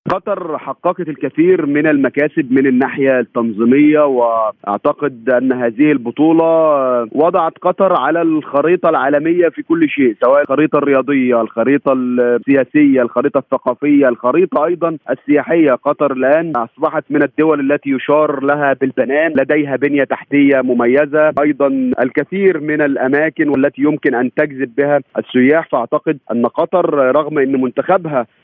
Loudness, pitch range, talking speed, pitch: -14 LUFS, 130-155 Hz, 125 wpm, 145 Hz